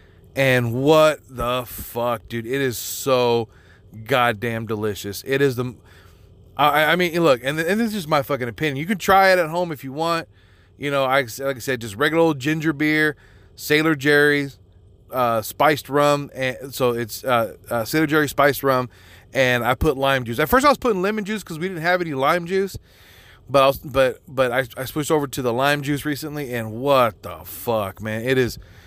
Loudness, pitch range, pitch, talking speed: -20 LUFS, 115-155 Hz, 135 Hz, 205 wpm